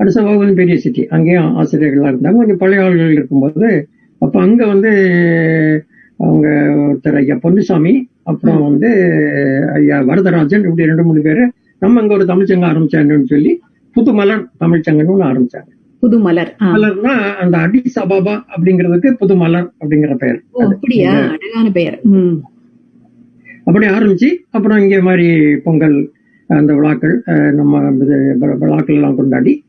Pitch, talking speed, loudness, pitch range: 175 Hz, 115 wpm, -11 LUFS, 150-210 Hz